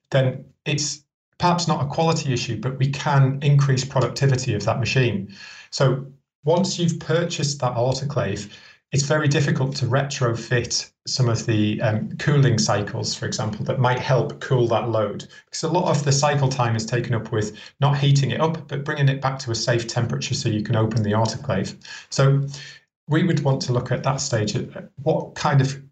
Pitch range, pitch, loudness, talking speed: 120-145 Hz, 135 Hz, -22 LUFS, 190 wpm